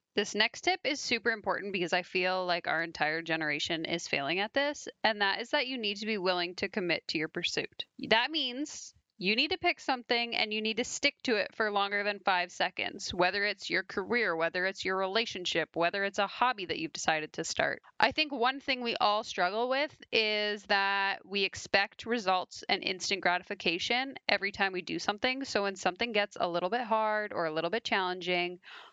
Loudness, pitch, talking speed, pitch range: -31 LUFS, 205 Hz, 210 wpm, 180-235 Hz